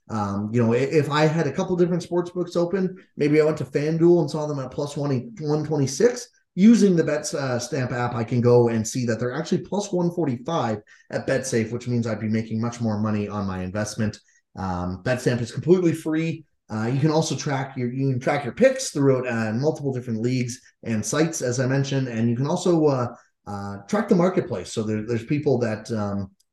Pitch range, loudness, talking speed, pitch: 115-160 Hz, -23 LUFS, 215 wpm, 135 Hz